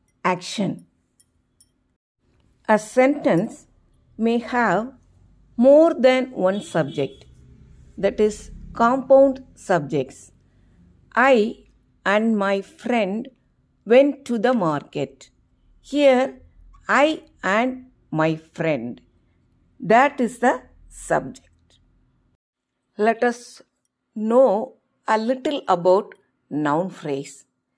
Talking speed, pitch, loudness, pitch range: 80 wpm, 215 Hz, -20 LUFS, 165-255 Hz